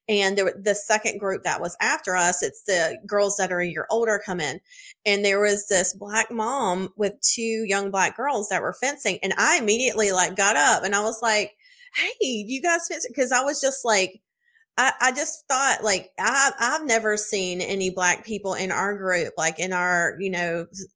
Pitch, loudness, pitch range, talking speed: 210 Hz, -23 LUFS, 190-250 Hz, 205 wpm